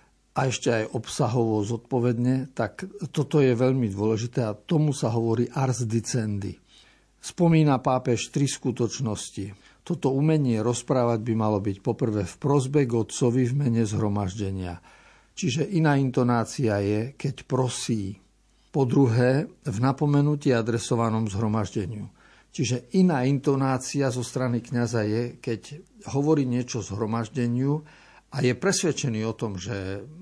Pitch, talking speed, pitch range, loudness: 125 Hz, 125 wpm, 110-140 Hz, -25 LUFS